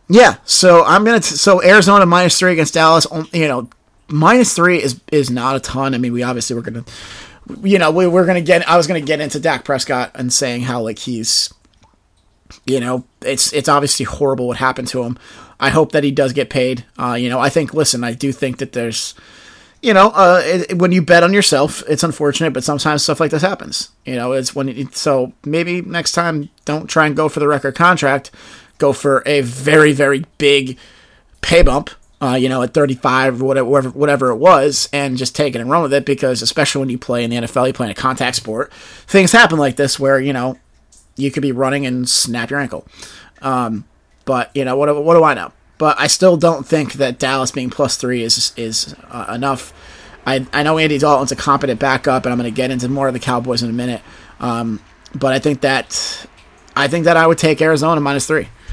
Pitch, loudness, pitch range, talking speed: 140 Hz, -14 LUFS, 125-155 Hz, 220 wpm